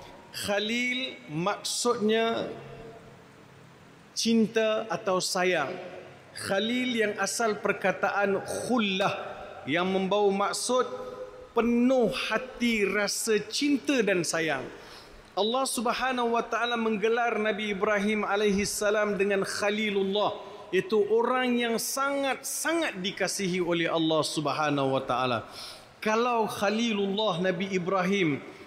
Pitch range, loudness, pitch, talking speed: 195-235 Hz, -27 LUFS, 210 Hz, 90 wpm